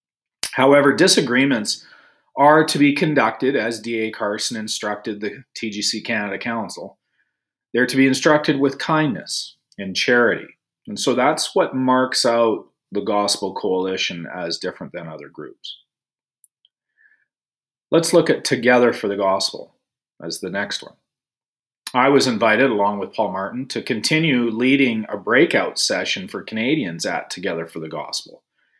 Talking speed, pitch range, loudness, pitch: 140 wpm, 105-135 Hz, -19 LUFS, 115 Hz